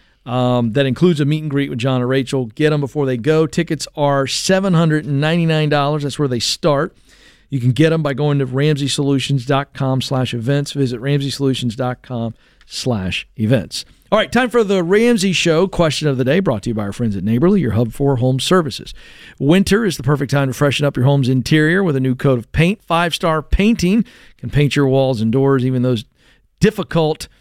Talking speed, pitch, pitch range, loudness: 210 wpm, 140 Hz, 130-160 Hz, -16 LUFS